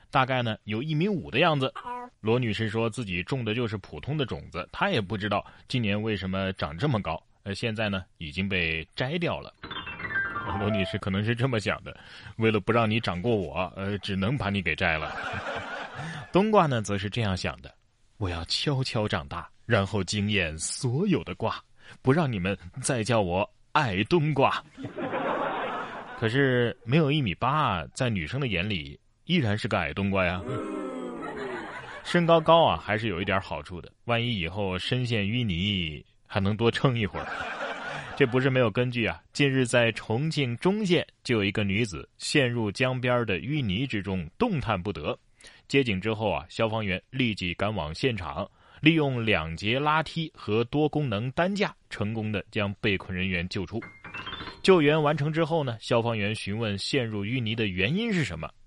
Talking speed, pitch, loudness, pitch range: 255 characters per minute, 110 Hz, -27 LUFS, 100-135 Hz